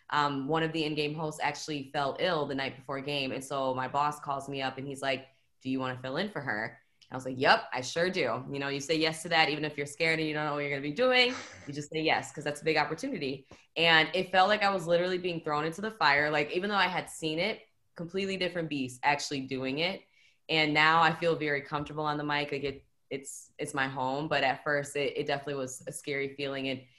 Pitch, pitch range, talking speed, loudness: 145 Hz, 135-160 Hz, 265 wpm, -30 LUFS